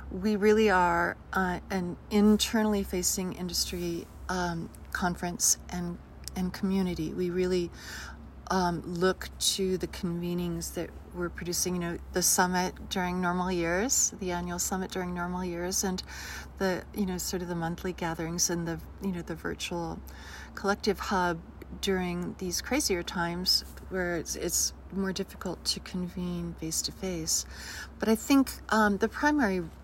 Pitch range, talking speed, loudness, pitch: 175-190 Hz, 145 wpm, -30 LUFS, 180 Hz